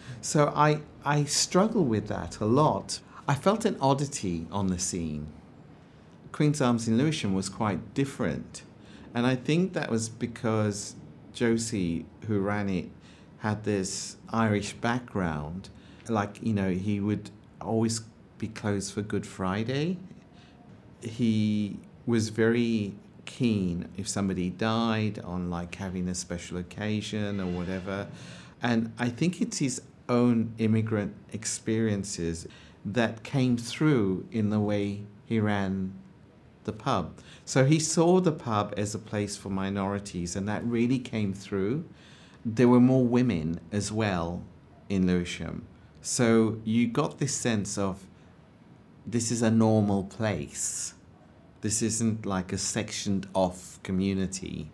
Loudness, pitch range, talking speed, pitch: -28 LUFS, 95-120 Hz, 135 wpm, 105 Hz